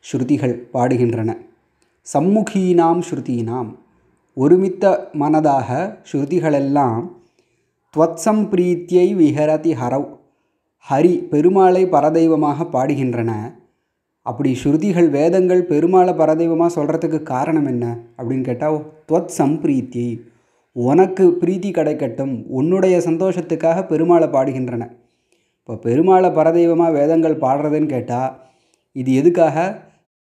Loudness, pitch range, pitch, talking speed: -17 LUFS, 130-175 Hz, 155 Hz, 85 wpm